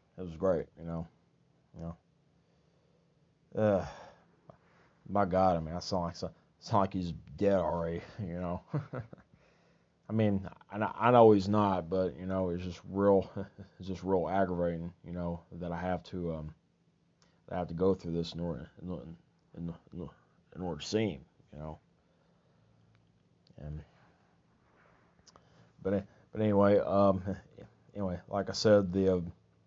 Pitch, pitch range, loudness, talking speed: 95 Hz, 85-100 Hz, -32 LUFS, 150 wpm